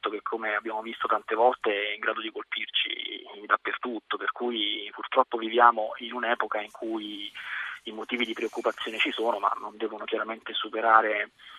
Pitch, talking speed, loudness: 120 Hz, 160 wpm, -28 LUFS